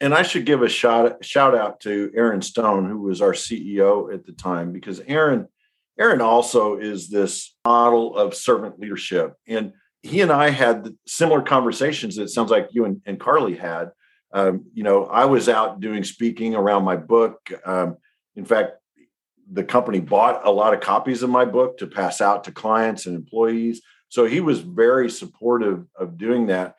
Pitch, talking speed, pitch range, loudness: 115 Hz, 185 wpm, 100-120 Hz, -20 LUFS